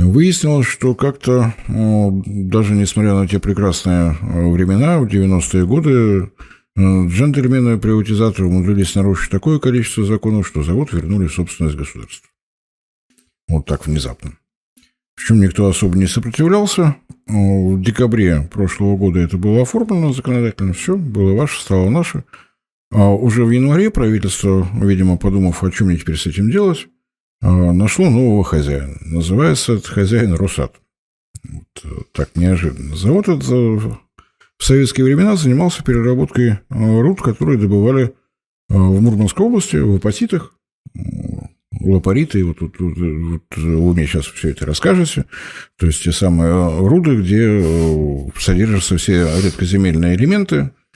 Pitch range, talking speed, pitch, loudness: 90-120 Hz, 125 wpm, 100 Hz, -15 LUFS